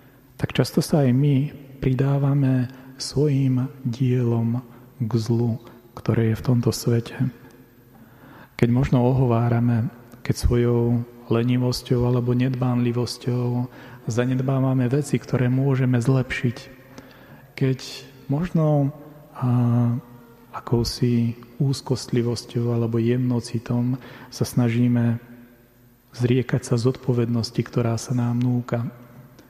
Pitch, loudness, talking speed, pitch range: 125 Hz, -23 LUFS, 90 wpm, 120-130 Hz